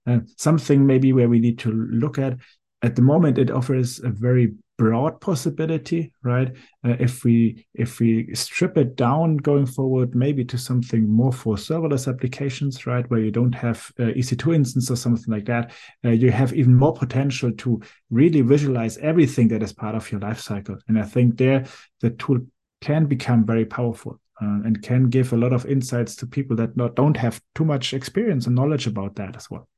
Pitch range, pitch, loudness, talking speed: 115-135 Hz, 125 Hz, -21 LUFS, 200 wpm